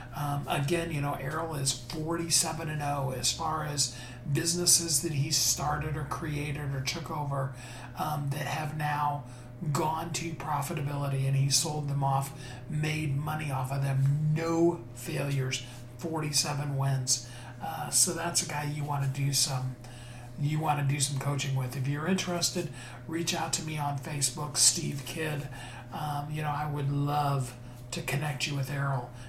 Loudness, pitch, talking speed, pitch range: -30 LUFS, 145 Hz, 165 wpm, 135-155 Hz